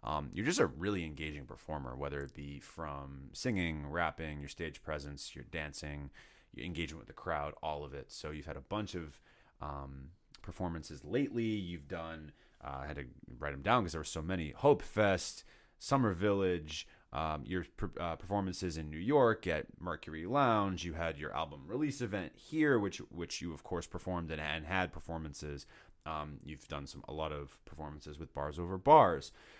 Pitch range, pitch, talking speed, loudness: 75-90 Hz, 80 Hz, 180 wpm, -37 LUFS